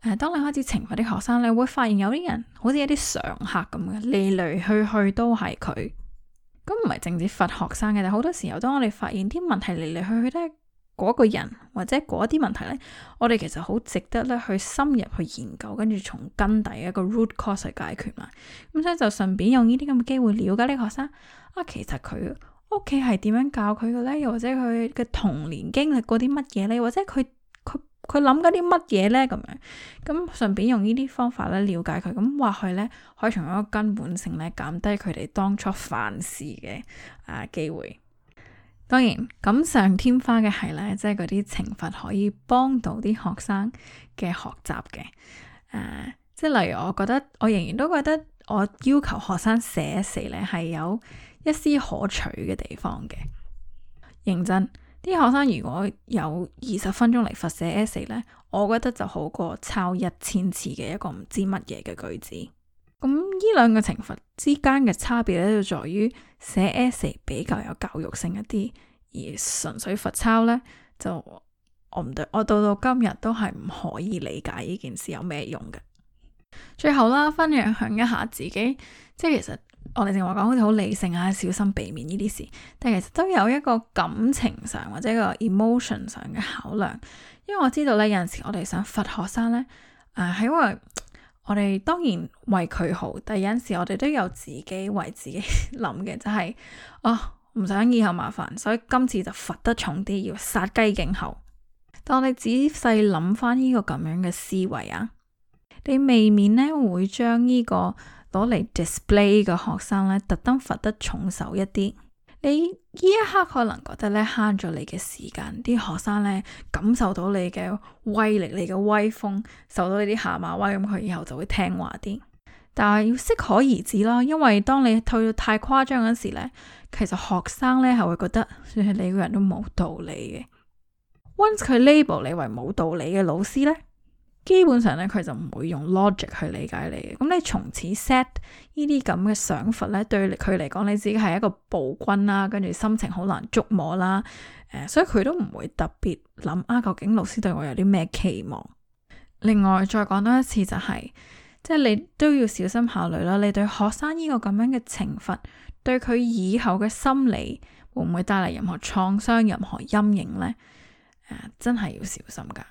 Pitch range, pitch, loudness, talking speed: 195-245 Hz, 215 Hz, -24 LUFS, 285 characters per minute